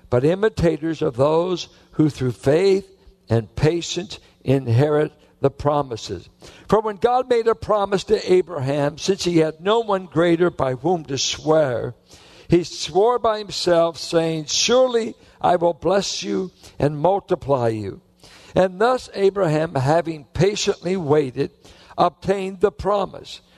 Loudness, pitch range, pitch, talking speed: -20 LUFS, 145-195 Hz, 170 Hz, 130 wpm